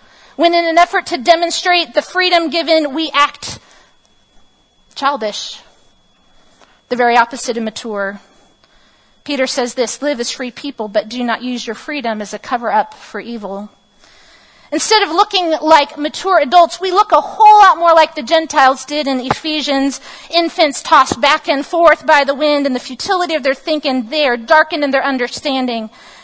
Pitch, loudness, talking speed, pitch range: 295 Hz, -13 LUFS, 165 wpm, 250-330 Hz